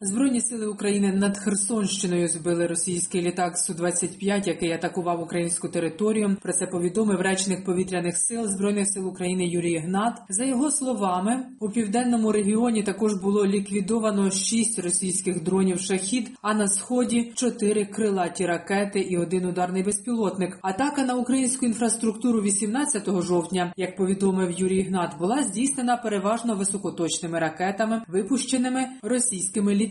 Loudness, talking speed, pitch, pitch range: -24 LUFS, 130 wpm, 200 Hz, 180-225 Hz